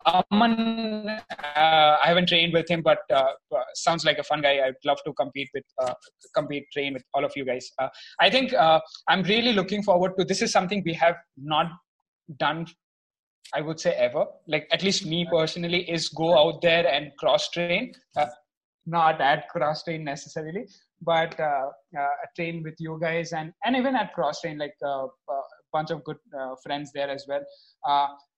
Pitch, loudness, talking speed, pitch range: 165 Hz, -25 LUFS, 190 wpm, 145-190 Hz